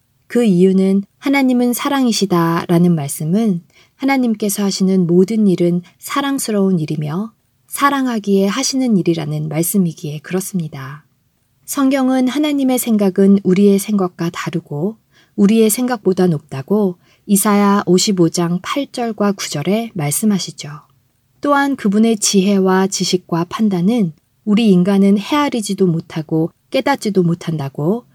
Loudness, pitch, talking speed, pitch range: -15 LUFS, 195 Hz, 290 characters per minute, 170-220 Hz